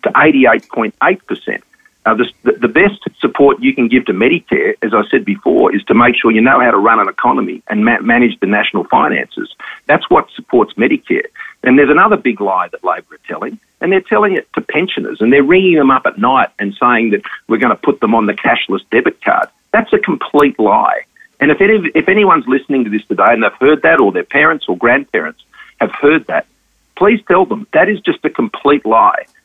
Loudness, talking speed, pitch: -12 LUFS, 215 wpm, 200 Hz